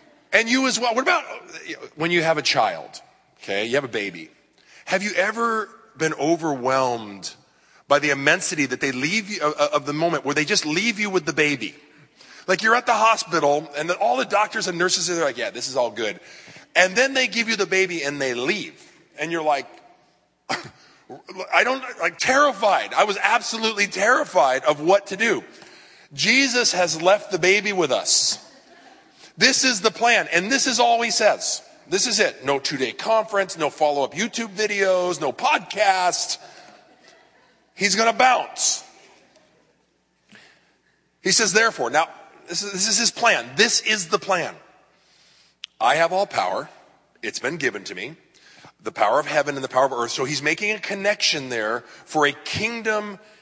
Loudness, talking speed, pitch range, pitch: -20 LUFS, 180 wpm, 160-235 Hz, 200 Hz